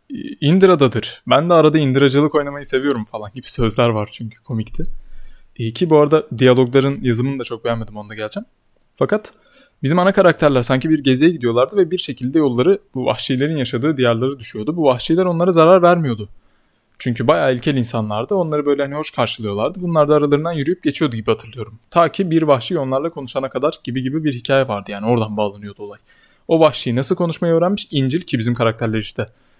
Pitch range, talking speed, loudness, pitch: 120-160 Hz, 180 wpm, -17 LUFS, 135 Hz